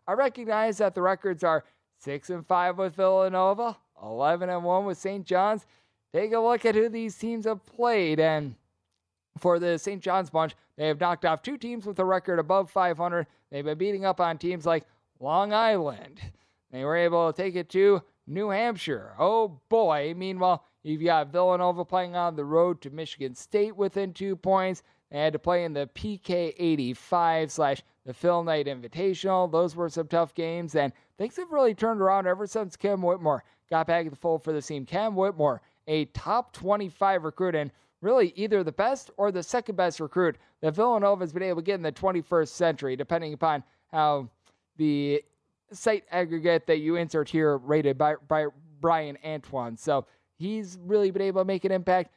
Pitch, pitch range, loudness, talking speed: 175 Hz, 155-195 Hz, -27 LUFS, 185 wpm